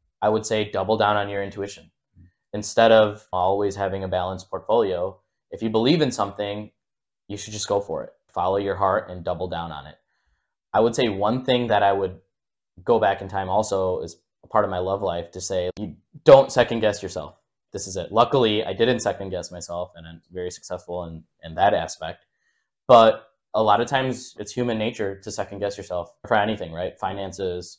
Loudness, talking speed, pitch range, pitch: -23 LUFS, 205 wpm, 90-105 Hz, 100 Hz